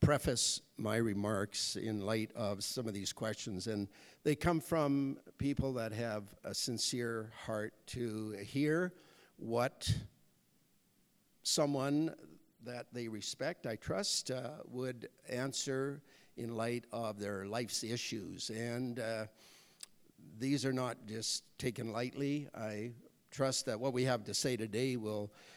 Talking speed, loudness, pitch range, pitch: 130 wpm, -38 LUFS, 110-135 Hz, 120 Hz